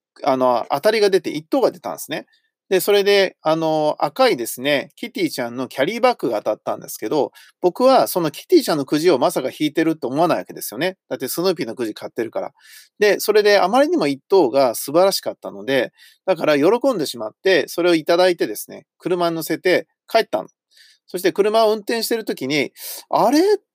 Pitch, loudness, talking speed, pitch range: 195 Hz, -19 LUFS, 415 characters per minute, 160-260 Hz